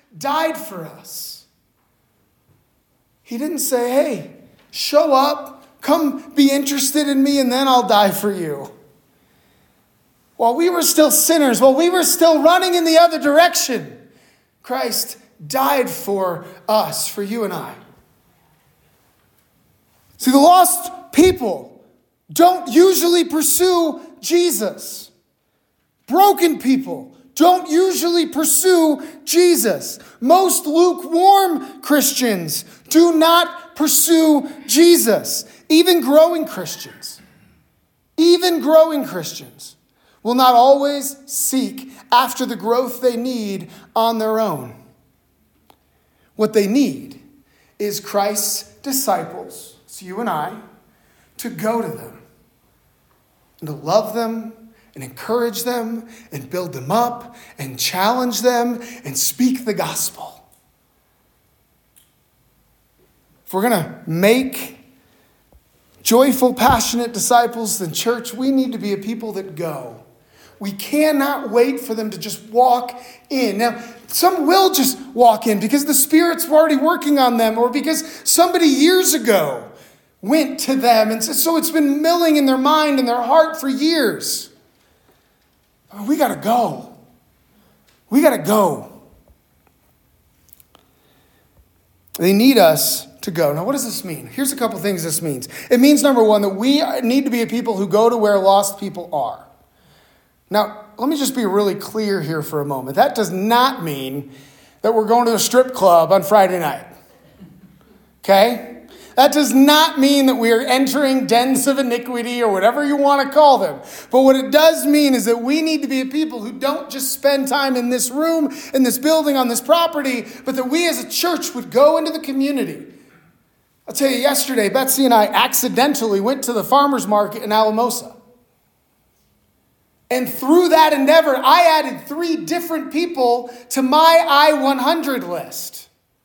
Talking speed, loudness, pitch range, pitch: 145 wpm, -16 LUFS, 220-300 Hz, 260 Hz